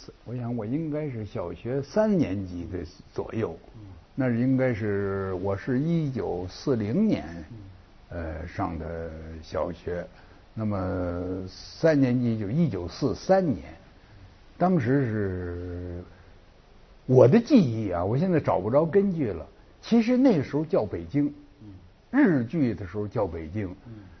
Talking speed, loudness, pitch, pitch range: 185 characters per minute, -26 LUFS, 105 Hz, 90-135 Hz